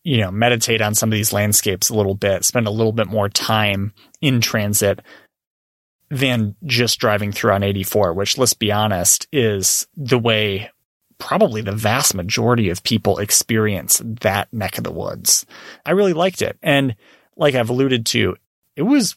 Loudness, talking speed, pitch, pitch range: -17 LUFS, 170 wpm, 110 Hz, 100-125 Hz